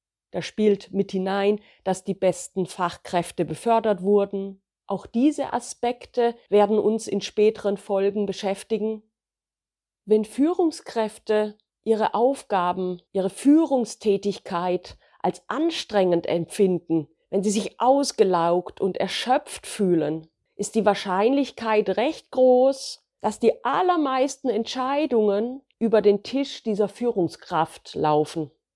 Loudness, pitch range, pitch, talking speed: -24 LUFS, 190-235 Hz, 210 Hz, 105 wpm